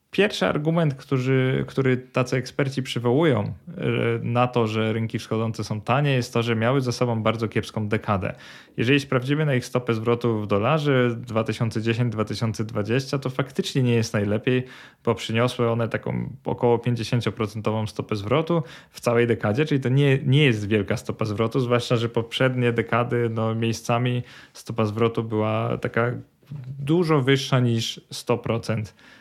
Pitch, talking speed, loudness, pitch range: 120 Hz, 145 wpm, -23 LUFS, 110-130 Hz